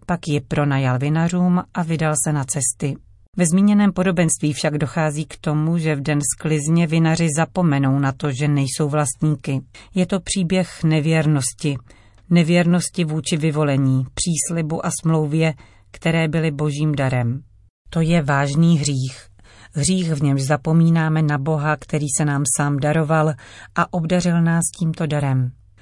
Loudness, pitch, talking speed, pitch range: -19 LUFS, 155 Hz, 140 wpm, 140-165 Hz